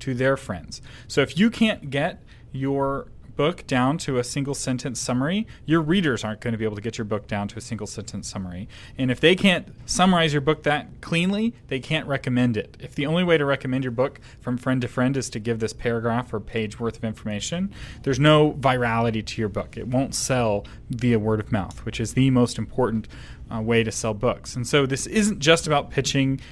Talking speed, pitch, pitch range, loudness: 220 wpm, 125 Hz, 115-145 Hz, -23 LUFS